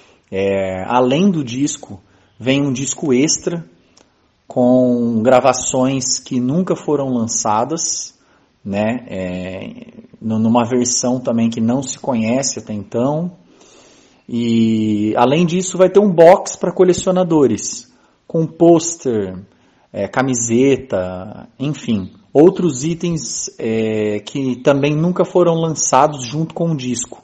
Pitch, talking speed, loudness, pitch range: 130 Hz, 110 wpm, -16 LUFS, 115-165 Hz